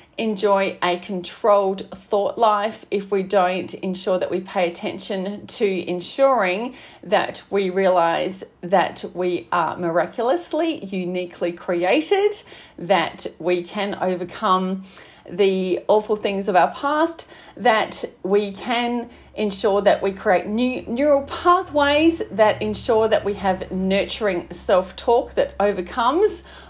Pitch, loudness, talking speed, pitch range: 200 Hz, -21 LUFS, 120 wpm, 185-230 Hz